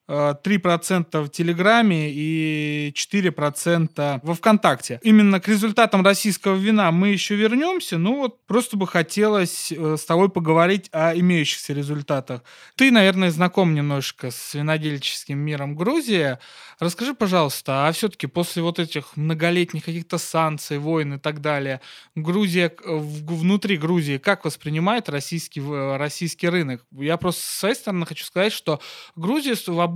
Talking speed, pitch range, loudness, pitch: 130 wpm, 150-195 Hz, -21 LUFS, 170 Hz